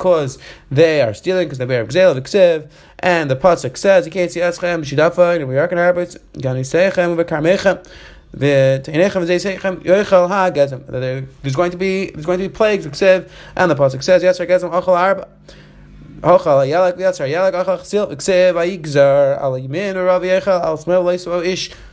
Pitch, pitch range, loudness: 175 Hz, 150-185 Hz, -16 LUFS